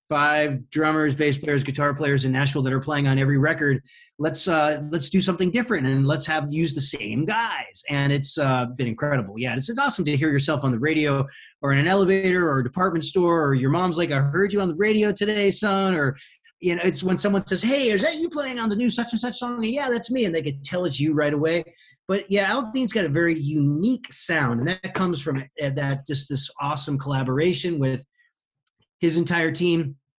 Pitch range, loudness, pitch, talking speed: 140-190 Hz, -23 LUFS, 155 Hz, 225 wpm